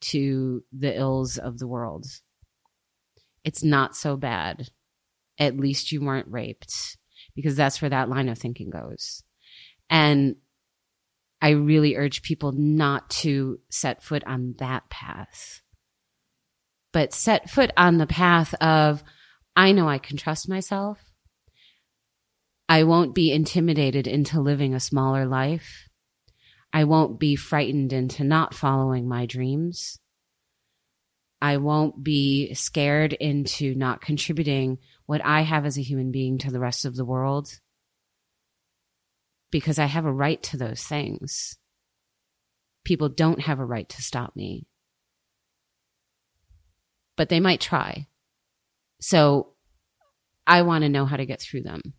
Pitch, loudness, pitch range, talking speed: 140 Hz, -23 LUFS, 130-155 Hz, 135 wpm